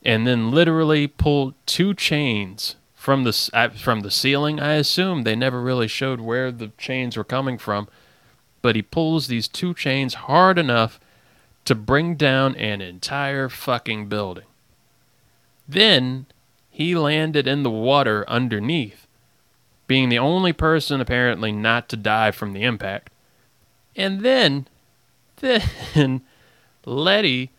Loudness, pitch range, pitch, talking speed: -20 LUFS, 115-145 Hz, 130 Hz, 130 wpm